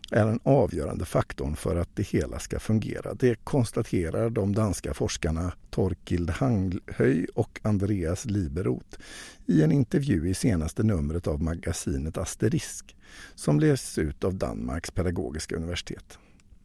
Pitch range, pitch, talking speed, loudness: 85-115 Hz, 95 Hz, 130 wpm, -28 LUFS